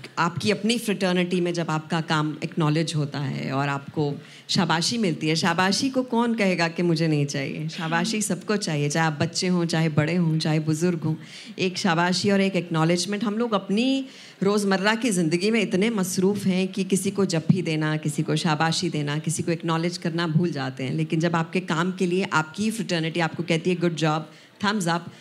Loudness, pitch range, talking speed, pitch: -24 LUFS, 160-195 Hz, 200 wpm, 170 Hz